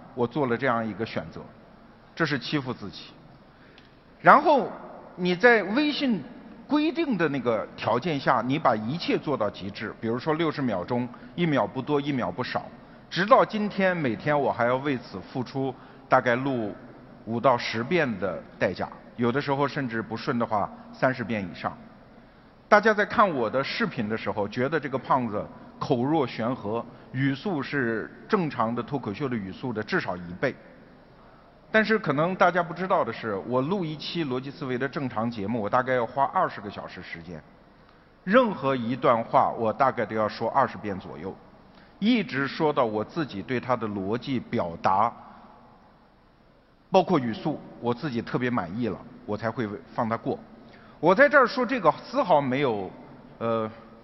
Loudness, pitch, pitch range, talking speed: -26 LUFS, 130 Hz, 115-165 Hz, 250 characters per minute